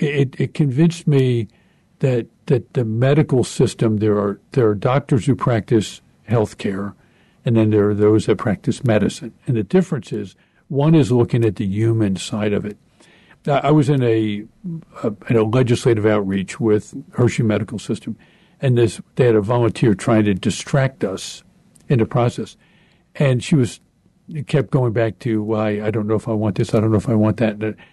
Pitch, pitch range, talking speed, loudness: 120 Hz, 110-140 Hz, 200 wpm, -18 LUFS